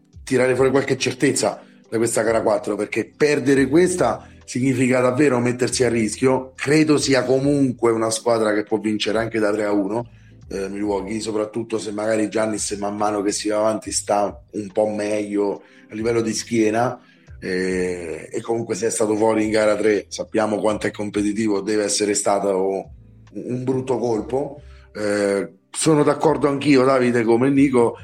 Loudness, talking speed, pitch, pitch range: -20 LUFS, 165 wpm, 110 Hz, 105-125 Hz